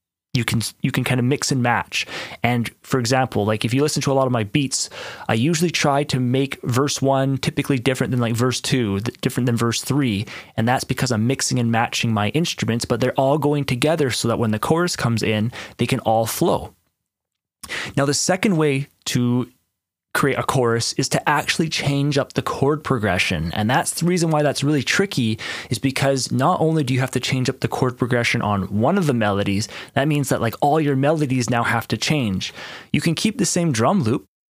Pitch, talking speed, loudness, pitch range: 130 Hz, 215 wpm, -20 LUFS, 115-145 Hz